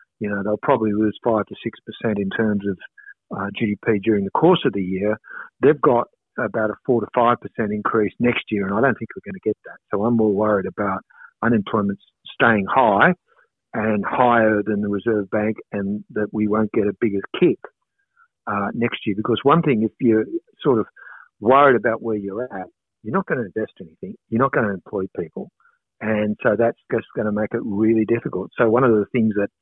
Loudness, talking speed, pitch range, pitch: -20 LUFS, 215 wpm, 105-115 Hz, 110 Hz